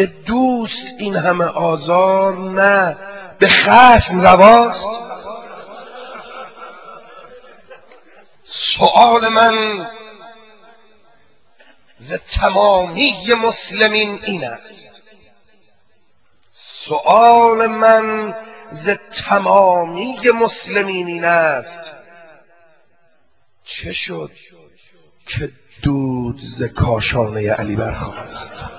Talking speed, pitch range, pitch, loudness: 65 wpm, 170-225 Hz, 200 Hz, -13 LUFS